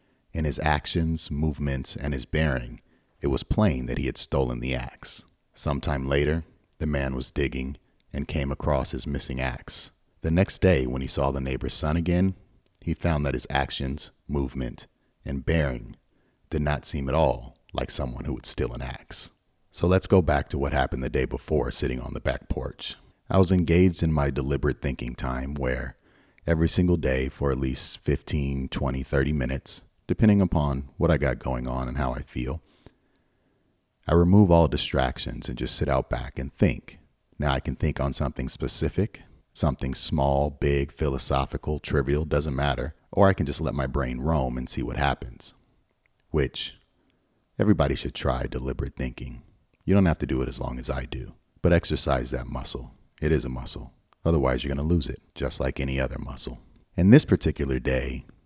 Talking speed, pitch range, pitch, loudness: 185 wpm, 65-80 Hz, 70 Hz, -26 LUFS